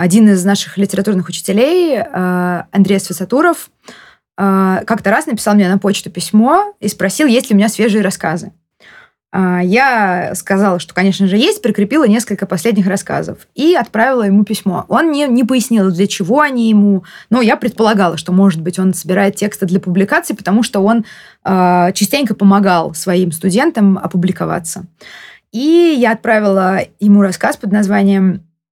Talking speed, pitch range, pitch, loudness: 145 wpm, 185-225 Hz, 200 Hz, -13 LUFS